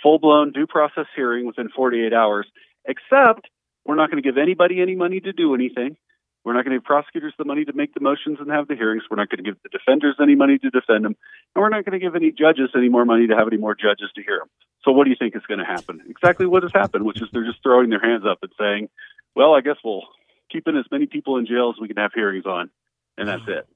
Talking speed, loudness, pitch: 280 wpm, -19 LUFS, 150 Hz